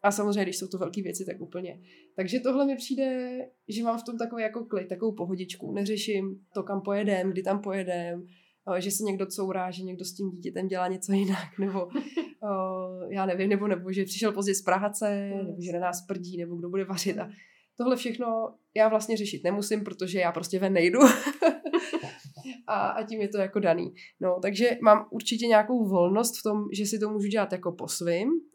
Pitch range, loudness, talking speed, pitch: 185-220 Hz, -28 LUFS, 200 wpm, 195 Hz